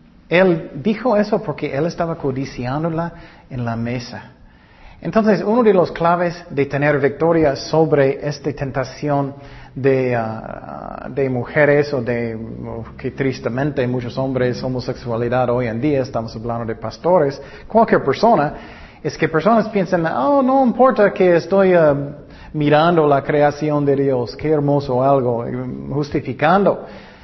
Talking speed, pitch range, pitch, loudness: 135 wpm, 130-170 Hz, 145 Hz, -18 LUFS